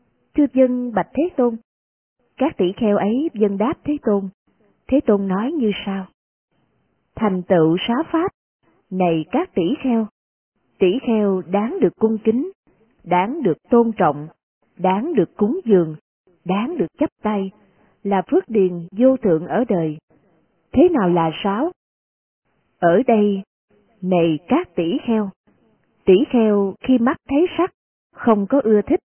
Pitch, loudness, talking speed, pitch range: 215 Hz, -19 LUFS, 145 wpm, 190-265 Hz